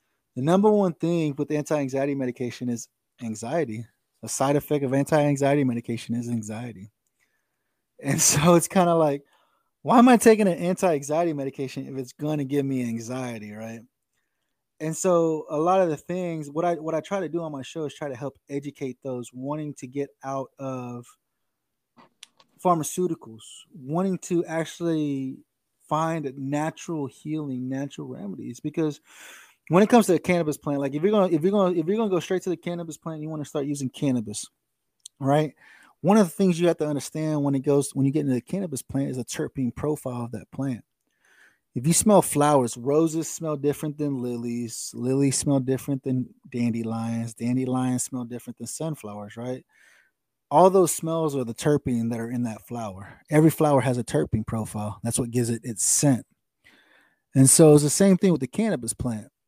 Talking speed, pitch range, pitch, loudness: 185 wpm, 125-160 Hz, 140 Hz, -24 LUFS